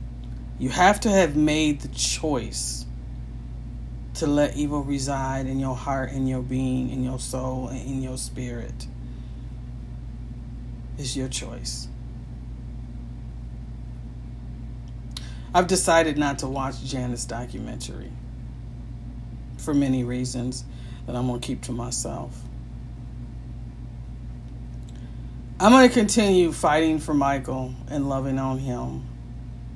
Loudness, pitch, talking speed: -24 LUFS, 125 Hz, 110 wpm